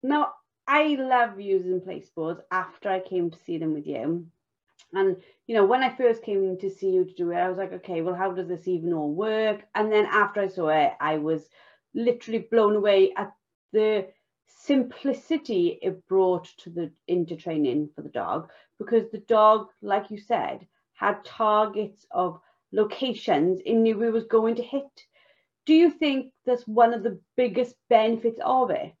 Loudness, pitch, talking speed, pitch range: -25 LUFS, 210 Hz, 180 wpm, 185-240 Hz